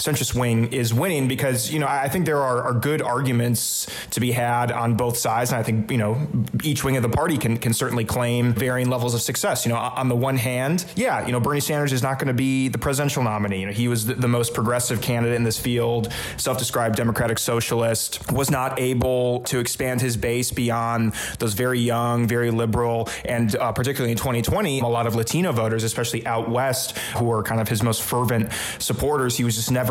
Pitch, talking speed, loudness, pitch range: 120 Hz, 220 wpm, -22 LUFS, 115-130 Hz